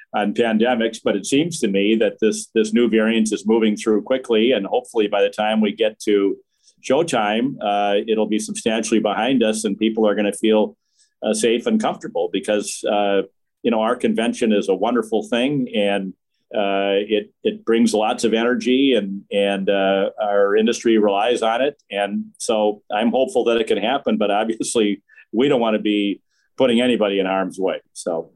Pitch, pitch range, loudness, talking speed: 105 Hz, 100-115 Hz, -19 LUFS, 185 wpm